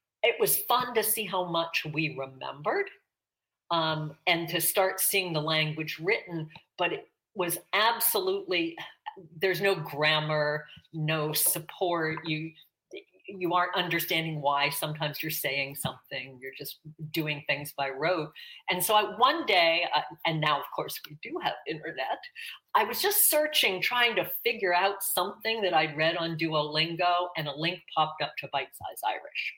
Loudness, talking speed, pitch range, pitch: -28 LUFS, 160 wpm, 155-195 Hz, 170 Hz